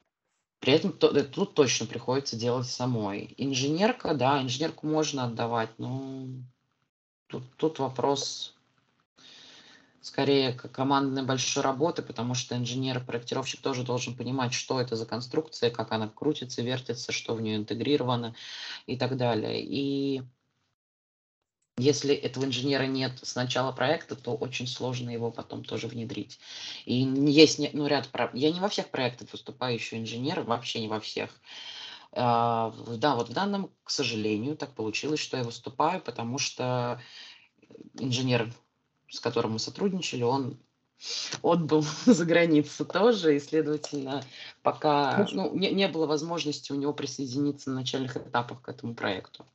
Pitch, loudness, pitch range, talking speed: 130 Hz, -29 LUFS, 120-145 Hz, 140 wpm